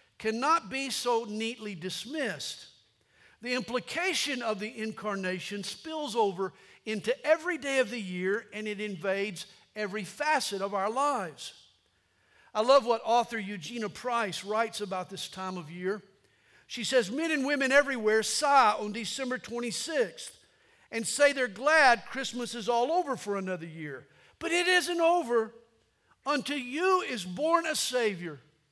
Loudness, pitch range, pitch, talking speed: -29 LUFS, 200-275 Hz, 230 Hz, 145 wpm